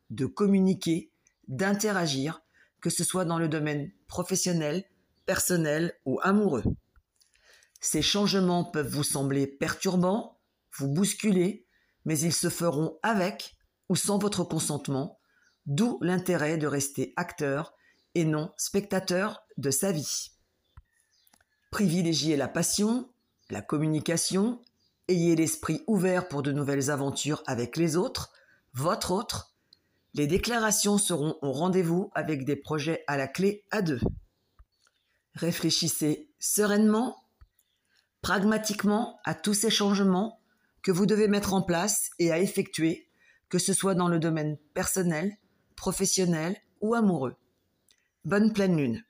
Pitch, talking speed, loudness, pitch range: 175 Hz, 120 wpm, -28 LUFS, 150-200 Hz